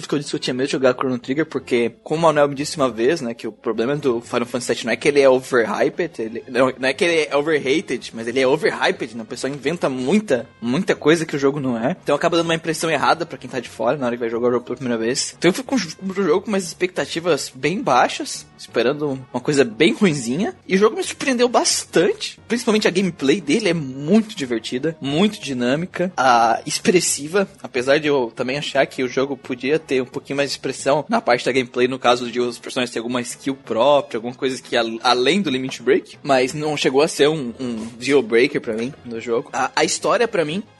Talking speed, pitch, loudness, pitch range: 240 wpm, 135 Hz, -20 LUFS, 125-160 Hz